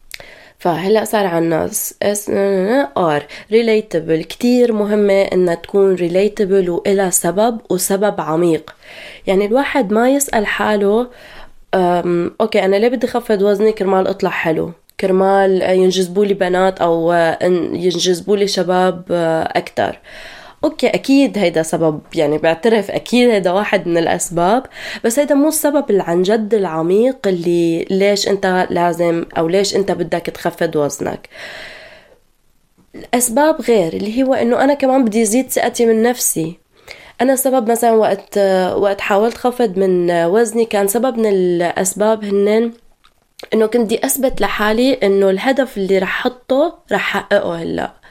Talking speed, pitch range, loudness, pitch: 130 wpm, 180-235 Hz, -15 LUFS, 200 Hz